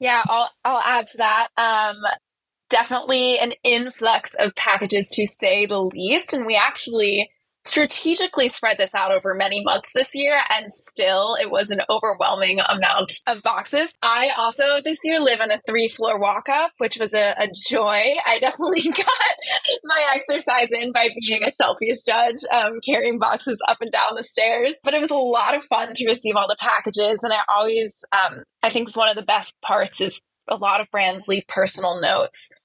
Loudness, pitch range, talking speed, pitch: -19 LUFS, 210-255 Hz, 190 wpm, 230 Hz